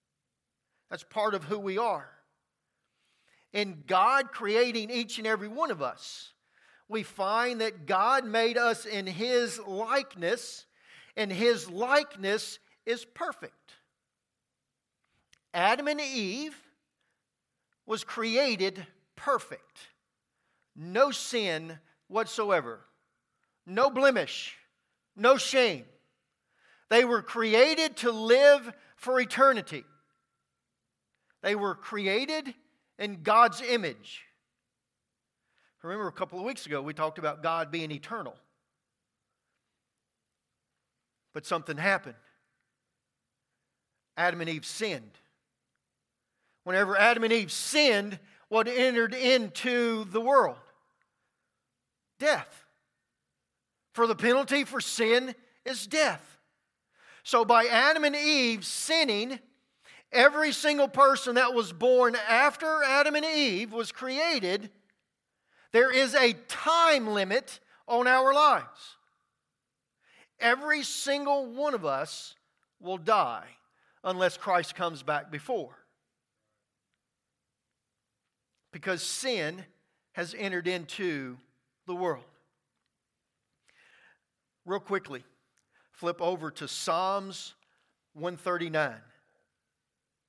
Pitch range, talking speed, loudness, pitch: 185-260 Hz, 95 wpm, -27 LUFS, 225 Hz